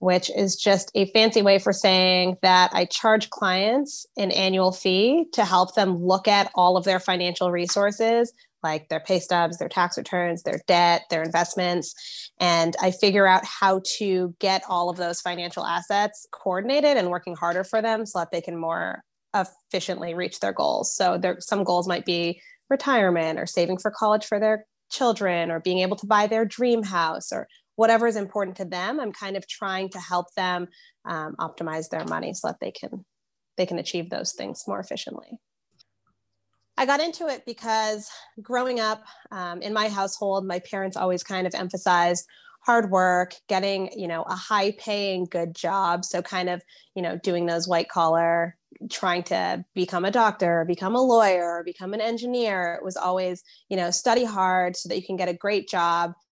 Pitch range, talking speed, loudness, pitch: 175-210 Hz, 185 wpm, -24 LUFS, 185 Hz